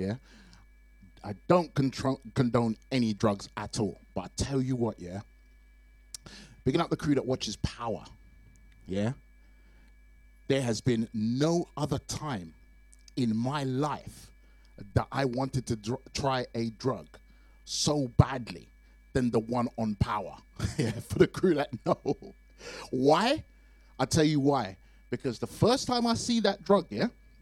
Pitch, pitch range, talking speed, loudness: 120 Hz, 100-135 Hz, 145 wpm, -30 LUFS